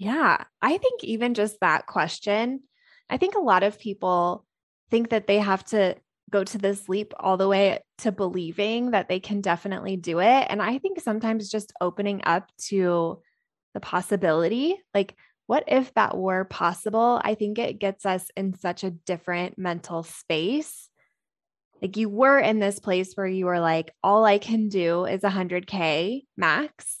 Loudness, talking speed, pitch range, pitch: -24 LUFS, 170 wpm, 185-225 Hz, 200 Hz